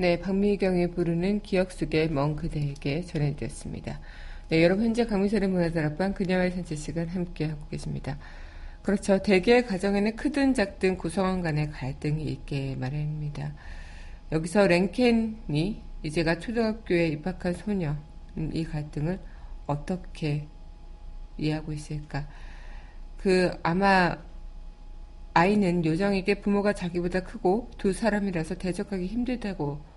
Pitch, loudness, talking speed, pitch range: 170 Hz, -27 LUFS, 300 characters per minute, 150-195 Hz